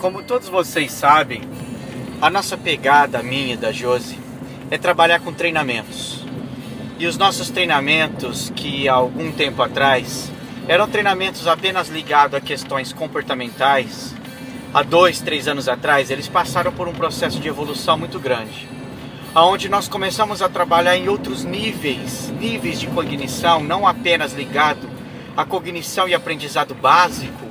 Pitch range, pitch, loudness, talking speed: 135-180 Hz, 165 Hz, -18 LUFS, 140 wpm